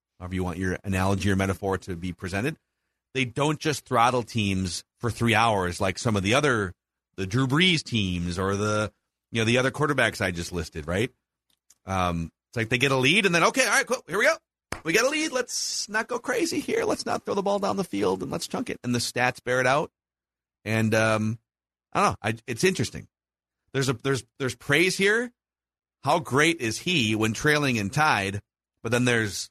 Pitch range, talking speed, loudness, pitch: 95-145 Hz, 215 wpm, -25 LUFS, 115 Hz